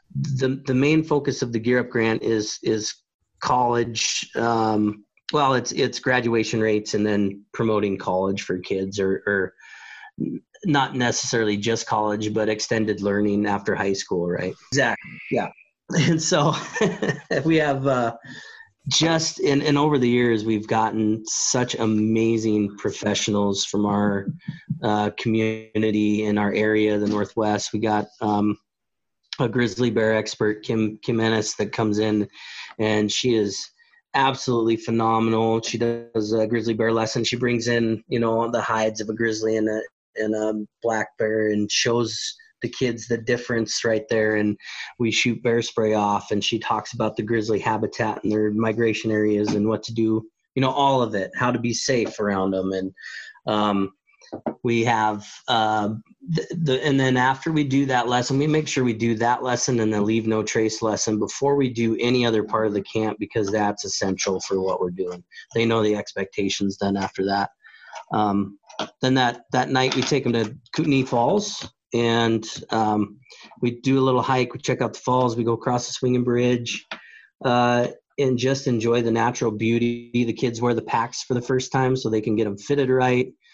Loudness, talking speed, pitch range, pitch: -23 LUFS, 175 wpm, 105-125 Hz, 115 Hz